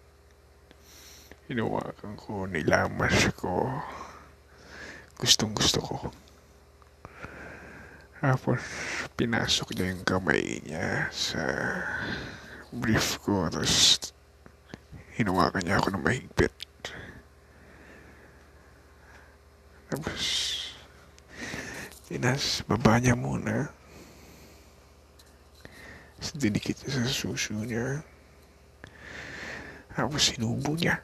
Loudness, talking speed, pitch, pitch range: -28 LUFS, 70 wpm, 80 Hz, 70-80 Hz